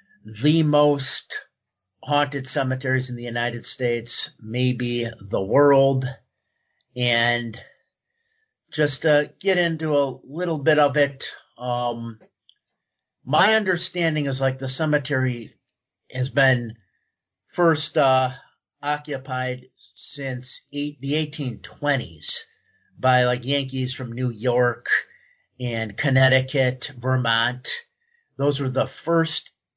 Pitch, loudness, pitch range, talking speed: 135 Hz, -22 LUFS, 125-150 Hz, 100 wpm